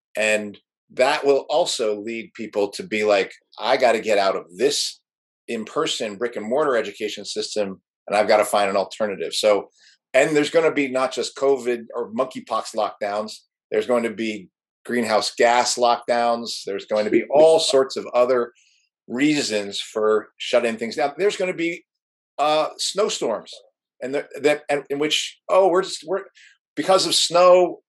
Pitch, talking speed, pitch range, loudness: 130 Hz, 170 wpm, 110-165 Hz, -21 LUFS